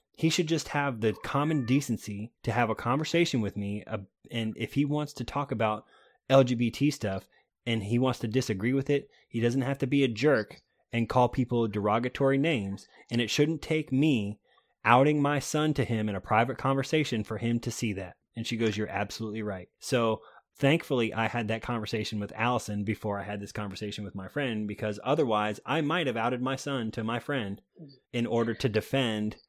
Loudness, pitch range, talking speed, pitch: -29 LUFS, 110-135 Hz, 200 wpm, 120 Hz